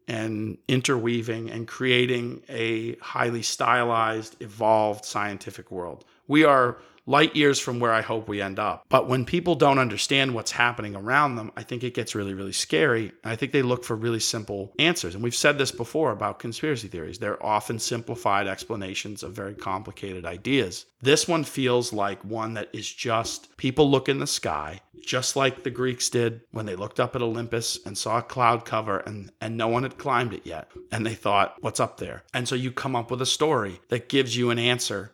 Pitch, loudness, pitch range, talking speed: 120 Hz, -25 LUFS, 110-130 Hz, 200 wpm